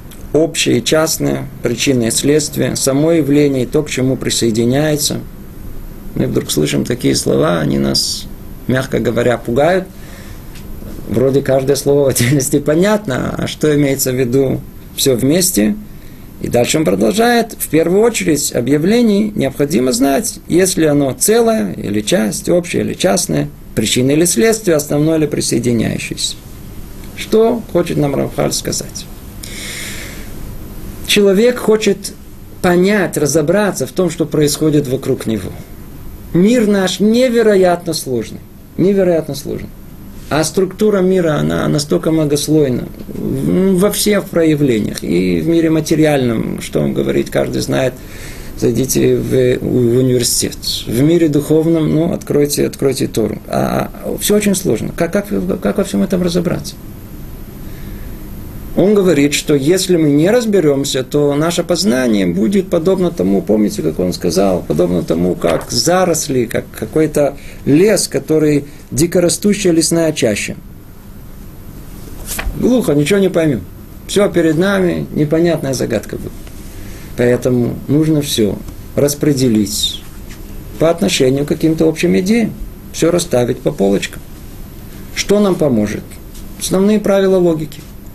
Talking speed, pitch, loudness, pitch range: 120 wpm, 145 Hz, -14 LUFS, 110-175 Hz